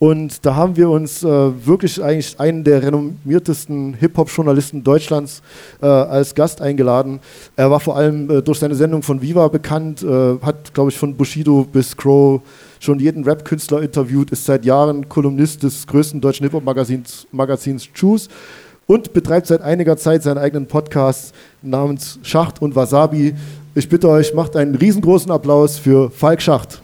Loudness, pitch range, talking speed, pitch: -15 LUFS, 140-155 Hz, 160 wpm, 145 Hz